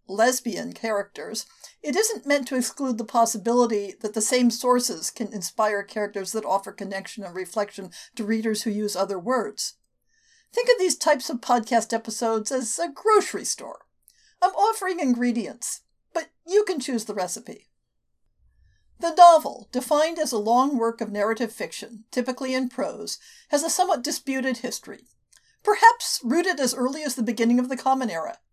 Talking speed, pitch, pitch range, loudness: 160 wpm, 245 Hz, 220-300 Hz, -24 LUFS